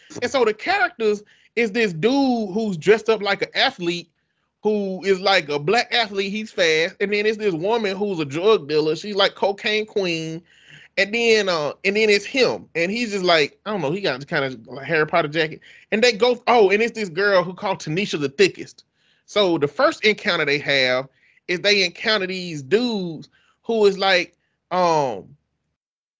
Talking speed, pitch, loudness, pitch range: 190 wpm, 200 Hz, -20 LUFS, 170-220 Hz